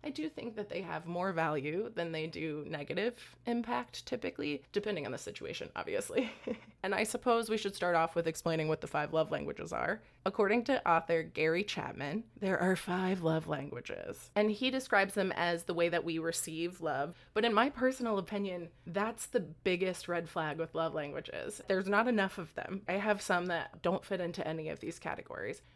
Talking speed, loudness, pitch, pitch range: 195 wpm, -35 LUFS, 185 Hz, 165-215 Hz